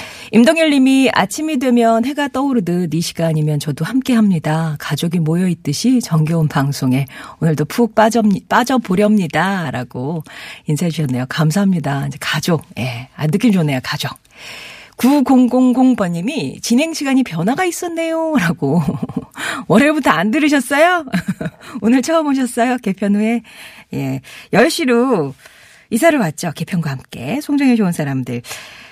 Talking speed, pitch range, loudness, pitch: 295 characters per minute, 160-255 Hz, -16 LUFS, 200 Hz